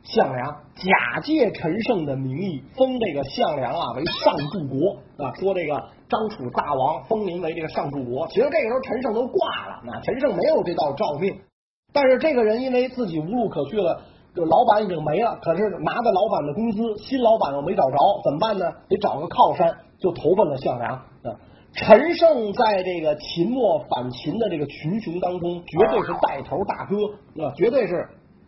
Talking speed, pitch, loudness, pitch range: 280 characters per minute, 185 Hz, -22 LUFS, 155-230 Hz